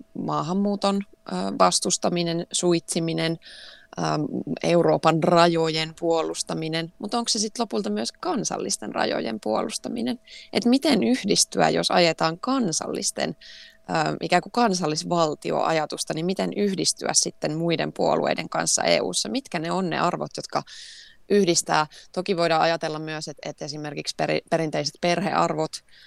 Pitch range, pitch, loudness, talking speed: 160-210 Hz, 175 Hz, -24 LUFS, 110 wpm